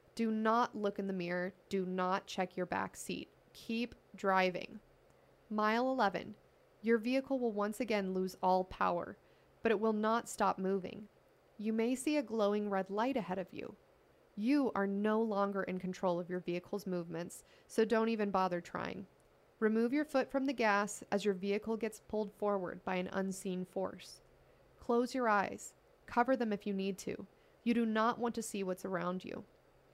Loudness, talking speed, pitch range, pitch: -36 LUFS, 180 wpm, 190-230 Hz, 205 Hz